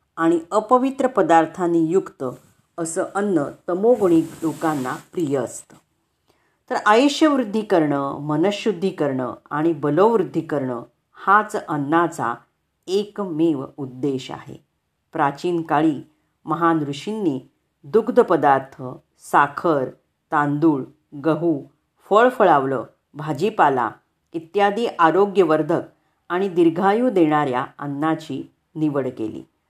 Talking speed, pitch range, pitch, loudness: 85 wpm, 145-195 Hz, 165 Hz, -20 LUFS